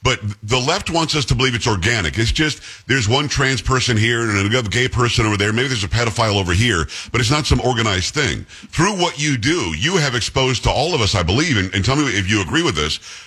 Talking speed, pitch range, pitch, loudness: 255 wpm, 105-135 Hz, 120 Hz, -17 LUFS